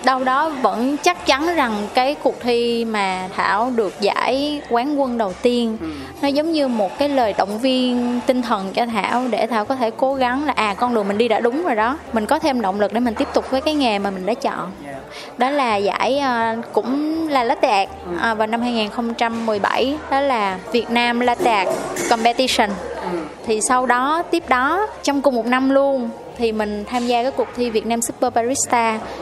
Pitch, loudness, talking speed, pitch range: 245 Hz, -19 LUFS, 205 wpm, 225-275 Hz